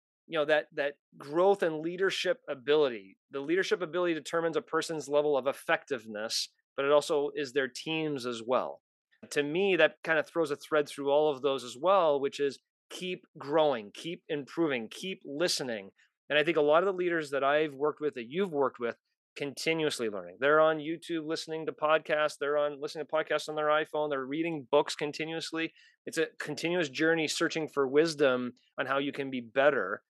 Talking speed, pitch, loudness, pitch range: 190 wpm, 150 Hz, -30 LUFS, 140-165 Hz